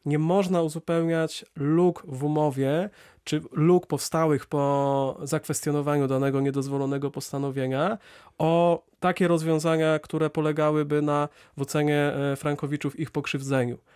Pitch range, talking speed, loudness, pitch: 140-160 Hz, 105 wpm, -26 LUFS, 150 Hz